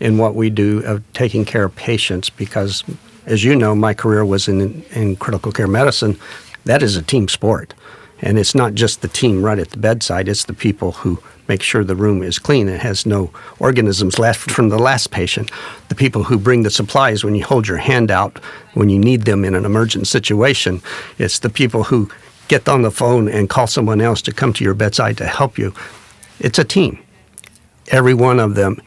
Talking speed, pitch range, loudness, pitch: 210 wpm, 100-120 Hz, -15 LUFS, 110 Hz